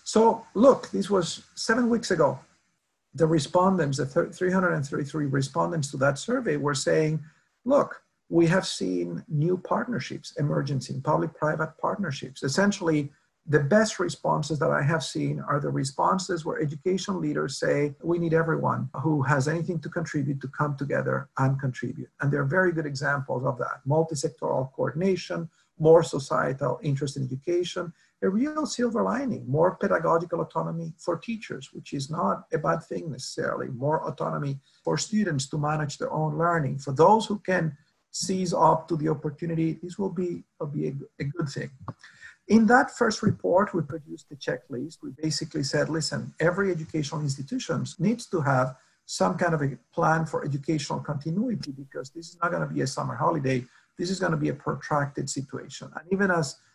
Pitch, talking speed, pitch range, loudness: 160 Hz, 170 wpm, 145-180 Hz, -26 LUFS